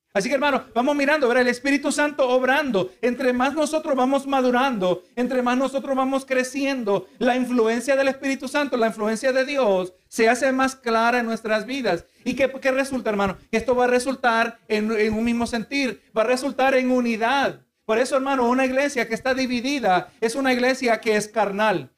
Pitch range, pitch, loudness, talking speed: 225-270 Hz, 250 Hz, -22 LUFS, 190 wpm